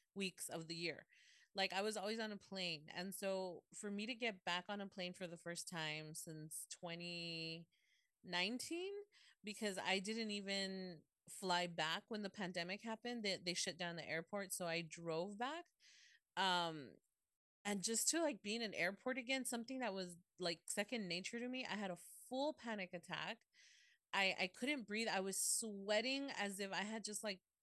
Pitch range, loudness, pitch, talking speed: 175-225 Hz, -44 LUFS, 195 Hz, 185 wpm